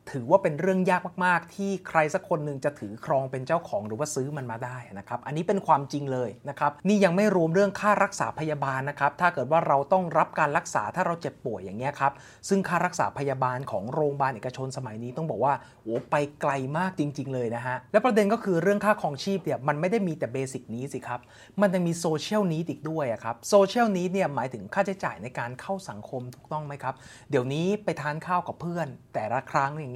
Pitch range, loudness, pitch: 130-180 Hz, -27 LUFS, 150 Hz